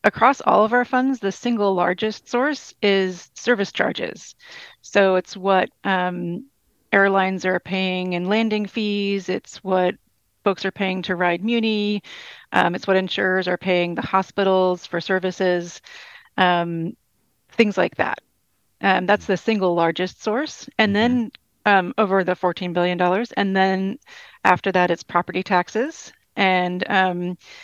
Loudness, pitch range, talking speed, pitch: -21 LUFS, 180-215 Hz, 145 wpm, 190 Hz